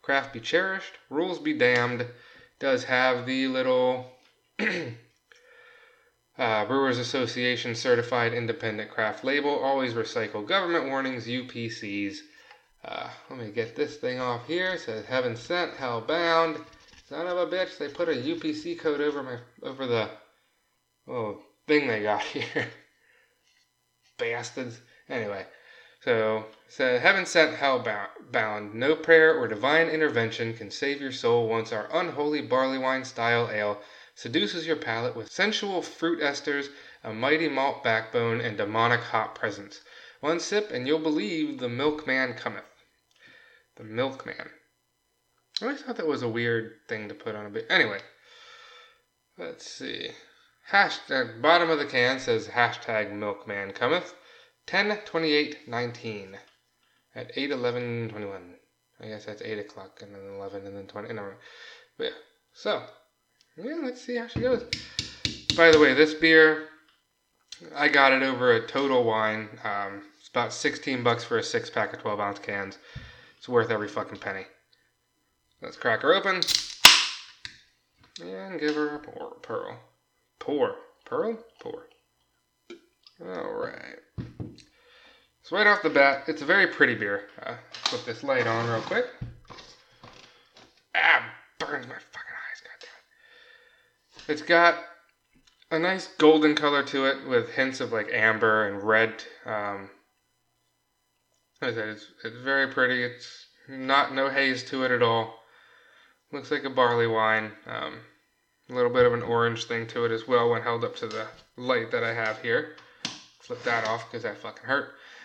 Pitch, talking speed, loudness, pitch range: 135 Hz, 145 wpm, -26 LUFS, 115-170 Hz